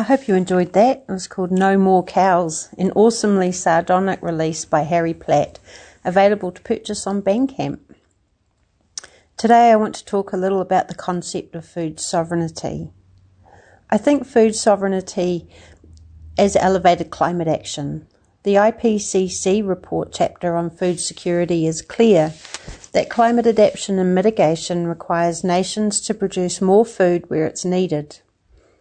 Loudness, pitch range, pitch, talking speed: -18 LUFS, 170-200 Hz, 185 Hz, 140 wpm